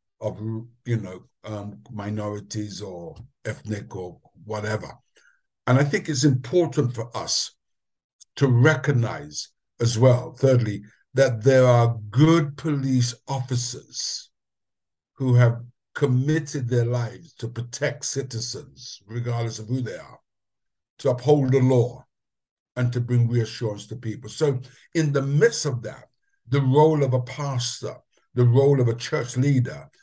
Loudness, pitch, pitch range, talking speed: -23 LUFS, 125 Hz, 115-140 Hz, 135 wpm